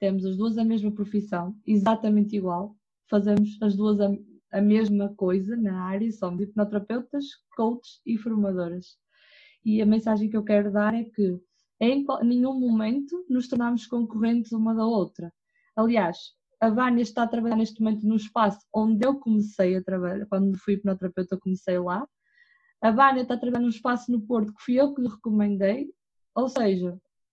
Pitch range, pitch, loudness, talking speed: 200-240 Hz, 220 Hz, -25 LUFS, 170 wpm